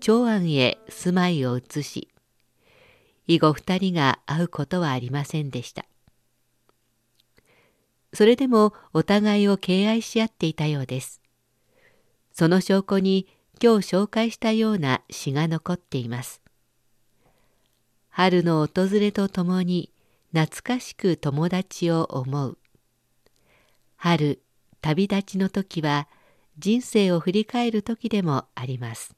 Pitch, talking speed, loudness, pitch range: 165 Hz, 220 characters per minute, -23 LUFS, 130-195 Hz